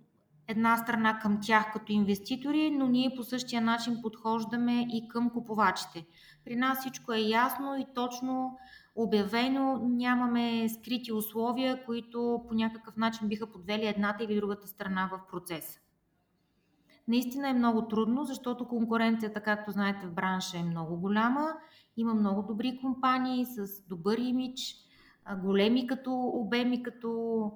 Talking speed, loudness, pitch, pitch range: 135 wpm, -31 LUFS, 230 Hz, 210-250 Hz